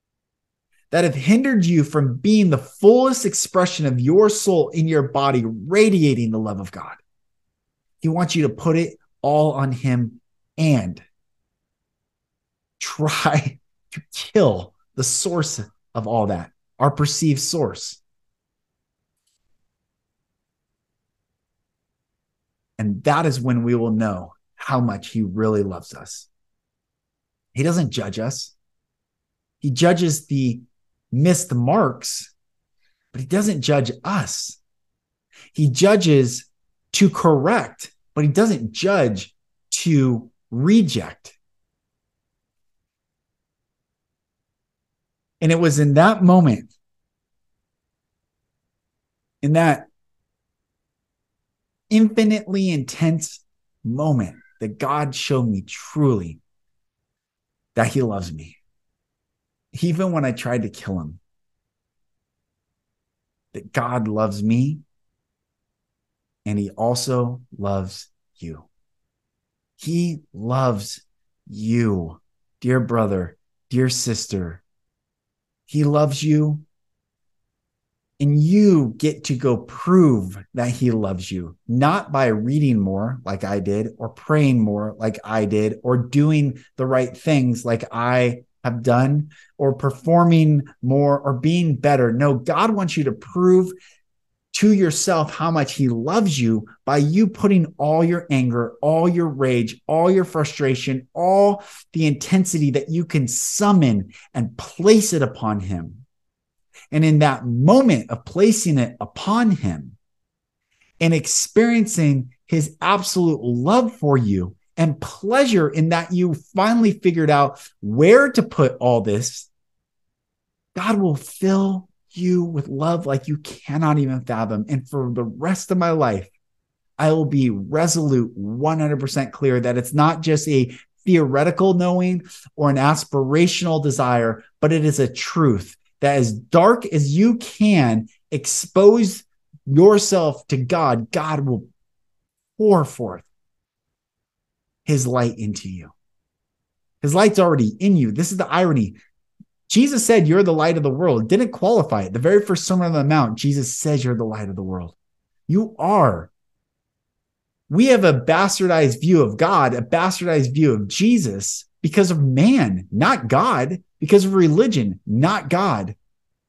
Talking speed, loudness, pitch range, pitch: 125 wpm, -19 LUFS, 115-170 Hz, 140 Hz